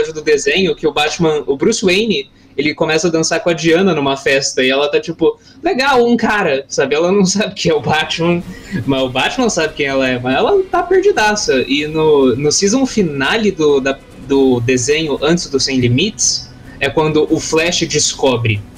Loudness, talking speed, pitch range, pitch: -14 LUFS, 190 wpm, 135-200 Hz, 155 Hz